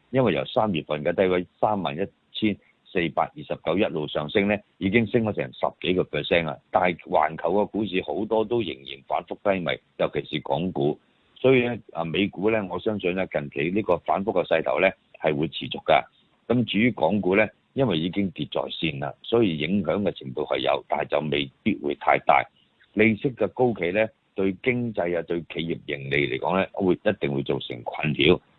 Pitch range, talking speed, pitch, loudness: 75-110 Hz, 300 characters per minute, 95 Hz, -25 LUFS